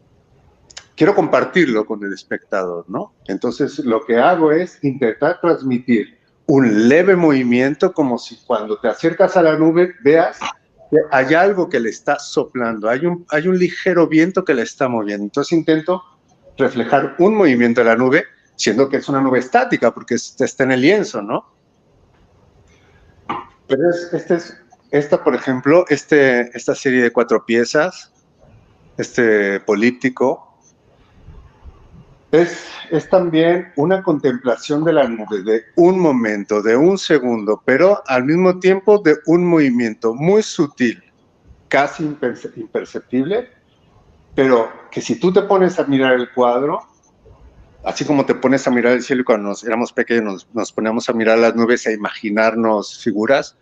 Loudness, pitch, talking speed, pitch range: -16 LUFS, 135 Hz, 150 wpm, 120-165 Hz